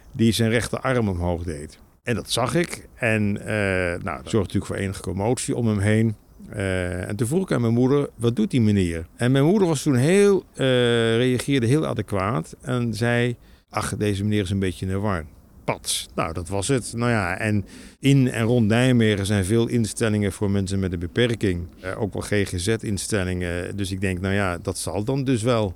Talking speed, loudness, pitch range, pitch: 200 wpm, -23 LUFS, 95-120 Hz, 105 Hz